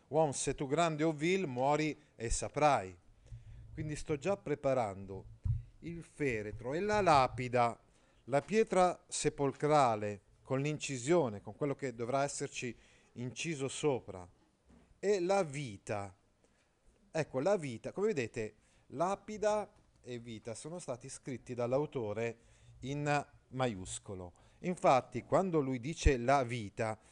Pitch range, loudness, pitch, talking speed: 115-150 Hz, -35 LUFS, 130 Hz, 115 wpm